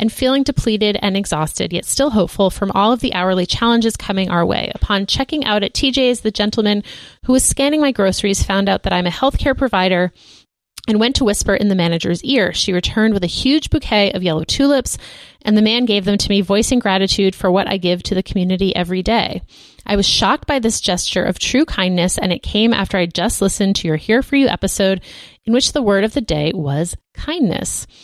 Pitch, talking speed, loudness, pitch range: 205 Hz, 220 wpm, -16 LUFS, 185-235 Hz